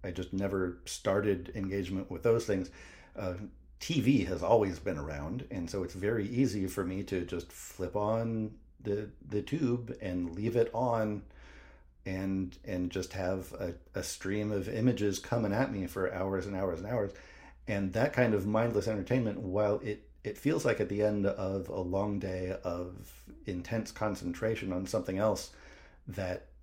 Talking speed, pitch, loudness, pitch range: 170 wpm, 95 Hz, -34 LUFS, 90-105 Hz